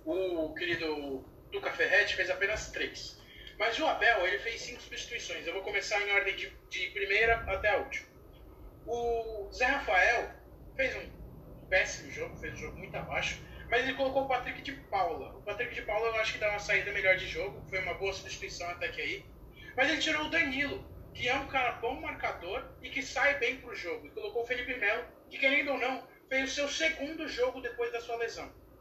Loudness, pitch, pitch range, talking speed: -32 LUFS, 235 Hz, 200-270 Hz, 205 wpm